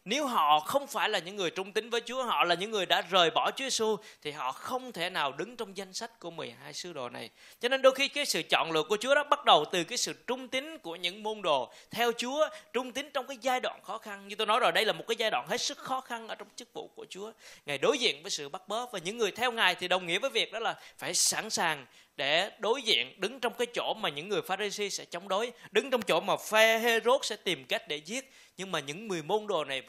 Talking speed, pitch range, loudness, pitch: 280 wpm, 190-255 Hz, -30 LUFS, 220 Hz